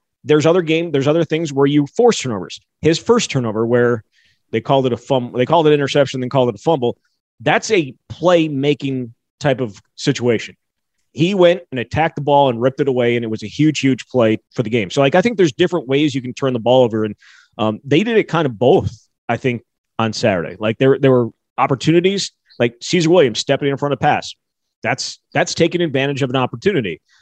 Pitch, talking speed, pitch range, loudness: 135 Hz, 225 wpm, 120-155 Hz, -17 LUFS